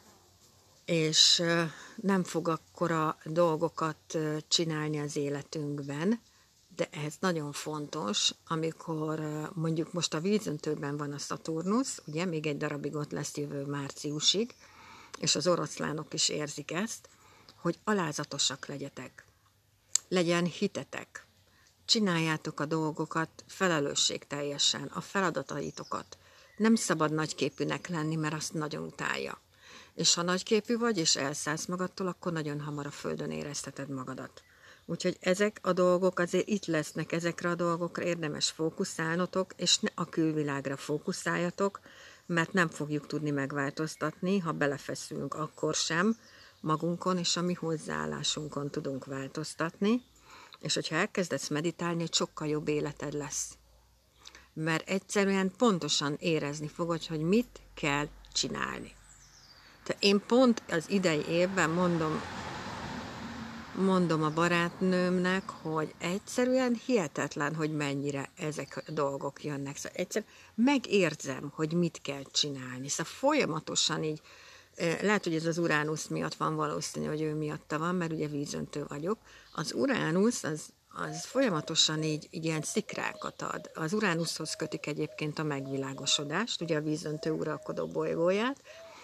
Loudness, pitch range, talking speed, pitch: -31 LUFS, 145-180 Hz, 125 wpm, 160 Hz